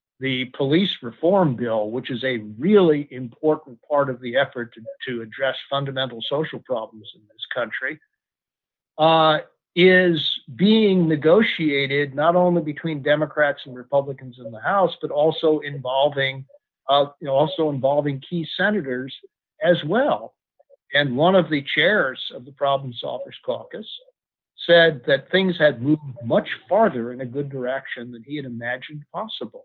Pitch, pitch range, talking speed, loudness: 145 Hz, 130-165 Hz, 150 wpm, -21 LUFS